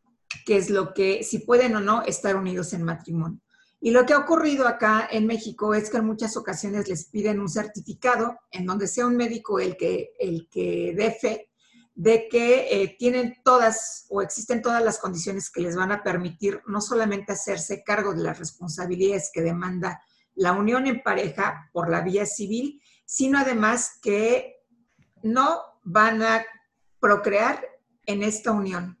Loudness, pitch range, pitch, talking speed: -24 LUFS, 195-240 Hz, 215 Hz, 170 wpm